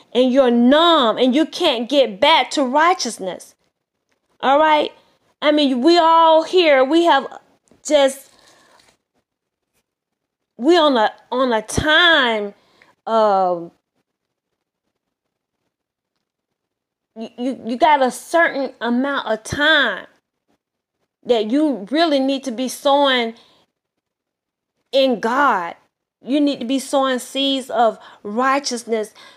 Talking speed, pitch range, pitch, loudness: 105 wpm, 240-300 Hz, 270 Hz, -16 LUFS